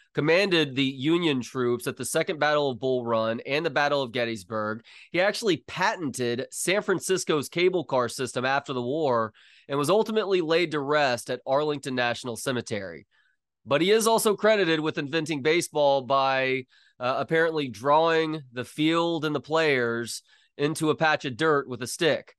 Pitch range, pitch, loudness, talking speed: 125-160 Hz, 145 Hz, -25 LUFS, 165 wpm